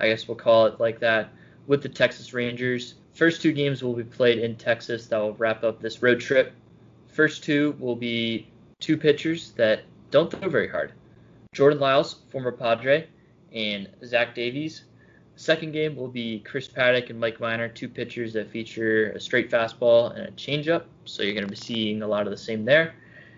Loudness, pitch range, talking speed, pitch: -24 LUFS, 115-140 Hz, 195 wpm, 120 Hz